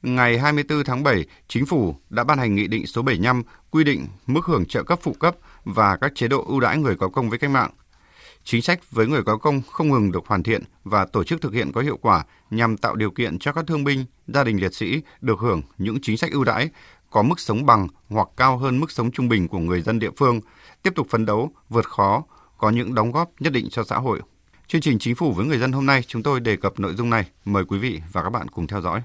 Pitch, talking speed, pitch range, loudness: 120 Hz, 260 wpm, 105-140 Hz, -22 LUFS